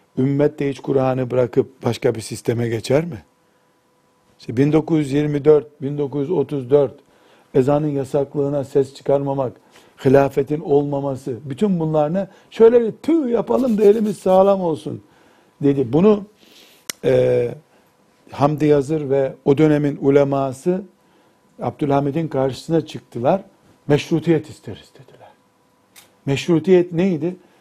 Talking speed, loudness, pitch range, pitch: 100 wpm, -19 LUFS, 135-165 Hz, 145 Hz